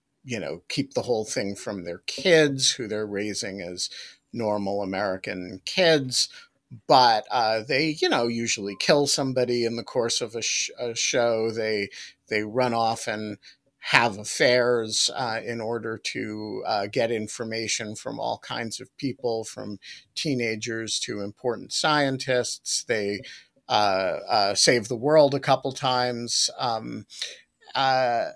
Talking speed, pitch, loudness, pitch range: 140 wpm, 115 Hz, -25 LUFS, 105-130 Hz